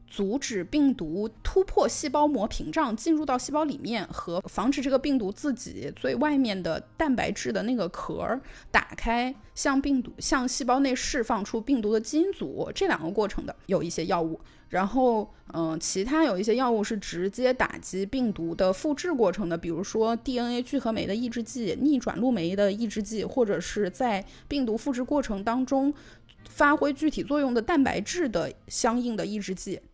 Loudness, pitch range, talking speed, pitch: -27 LUFS, 200-280 Hz, 285 characters per minute, 240 Hz